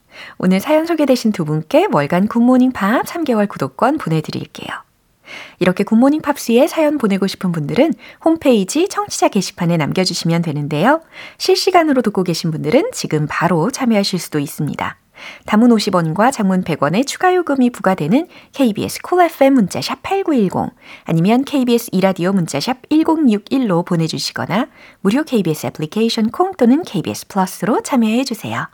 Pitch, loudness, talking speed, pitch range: 225 Hz, -16 LUFS, 355 characters per minute, 180-275 Hz